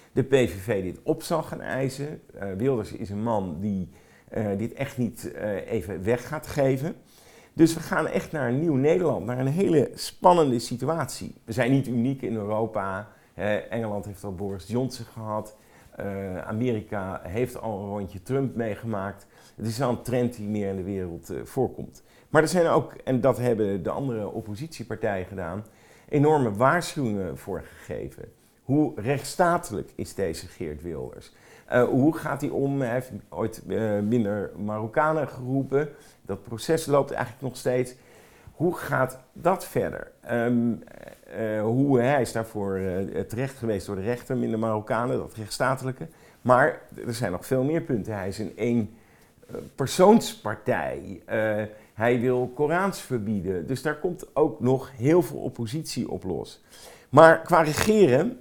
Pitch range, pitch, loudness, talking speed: 105-135 Hz, 120 Hz, -26 LUFS, 160 wpm